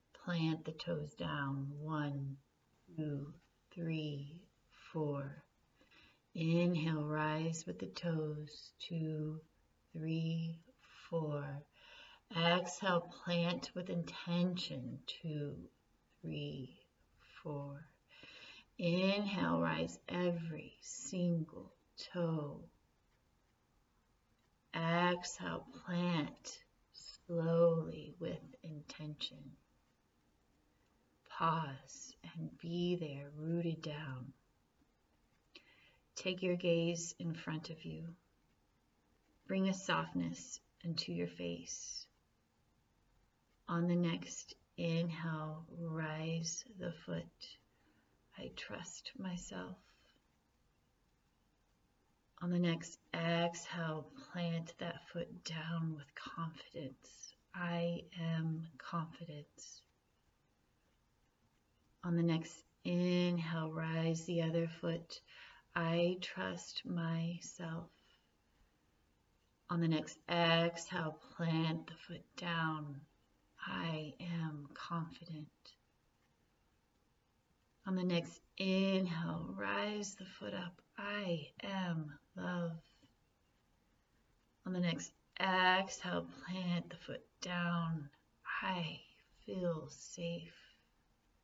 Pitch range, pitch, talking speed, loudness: 150-175 Hz, 165 Hz, 80 wpm, -40 LUFS